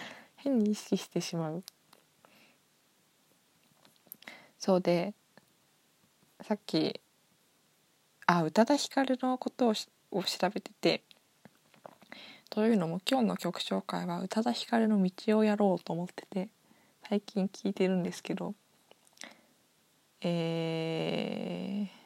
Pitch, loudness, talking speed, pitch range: 205 Hz, -32 LUFS, 200 characters per minute, 175-225 Hz